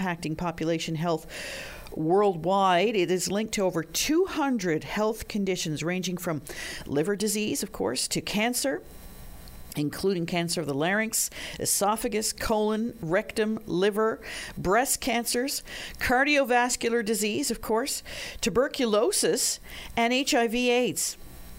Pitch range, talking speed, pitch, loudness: 170-235 Hz, 110 wpm, 210 Hz, -27 LUFS